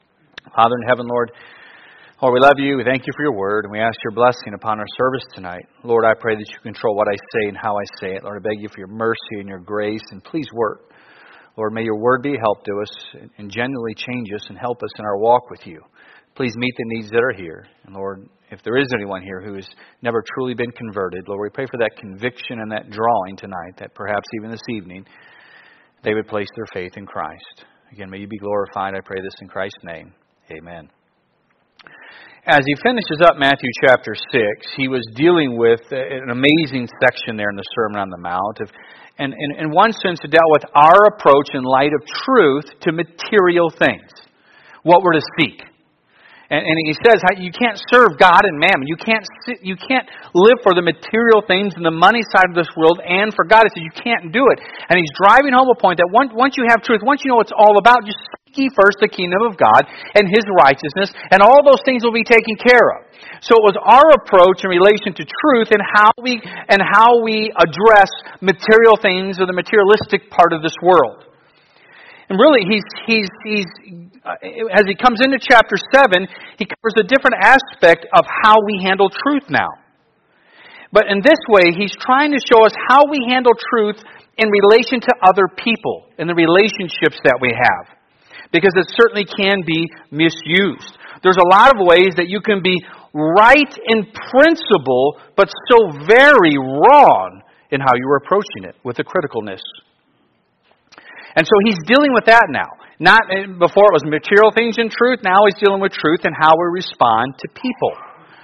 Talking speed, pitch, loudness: 205 wpm, 180 Hz, -14 LUFS